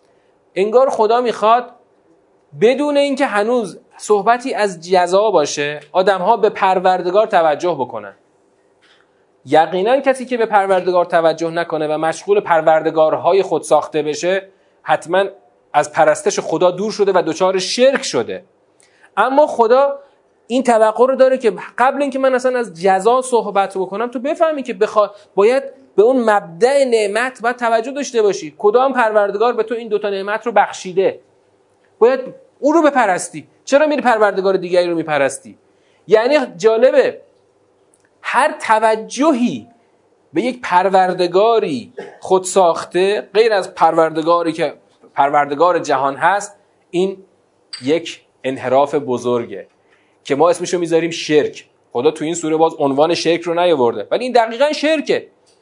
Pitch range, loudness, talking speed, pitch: 170-255 Hz, -15 LUFS, 135 wpm, 205 Hz